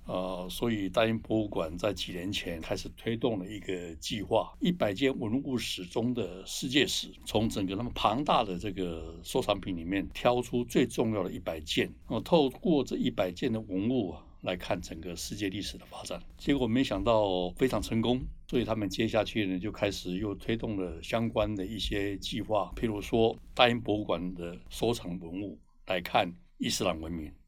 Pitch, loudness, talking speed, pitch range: 100 Hz, -31 LUFS, 285 characters per minute, 90-115 Hz